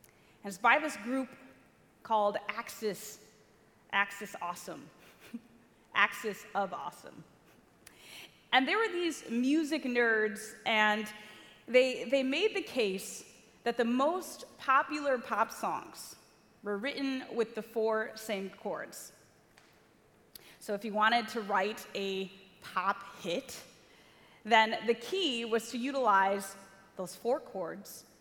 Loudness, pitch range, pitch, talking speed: -32 LUFS, 205-255 Hz, 220 Hz, 115 wpm